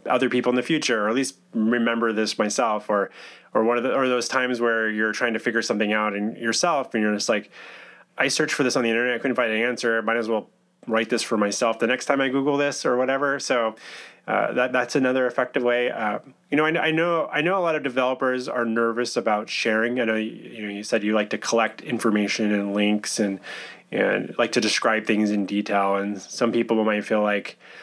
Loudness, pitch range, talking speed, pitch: -23 LUFS, 110-125 Hz, 235 wpm, 115 Hz